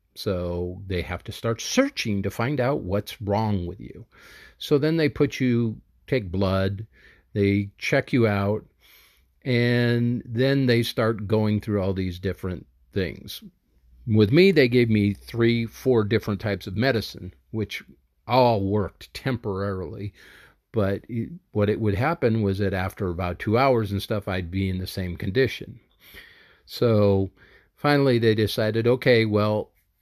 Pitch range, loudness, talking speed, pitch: 95-120 Hz, -24 LUFS, 150 wpm, 105 Hz